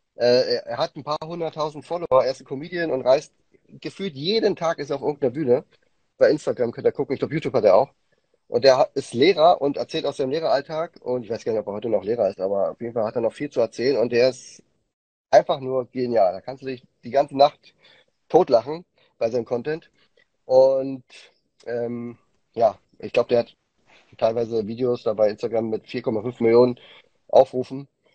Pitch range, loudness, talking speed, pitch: 120-165 Hz, -22 LUFS, 200 wpm, 135 Hz